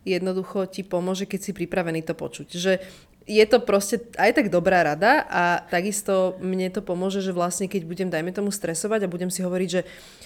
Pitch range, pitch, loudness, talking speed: 180-195 Hz, 185 Hz, -24 LUFS, 195 wpm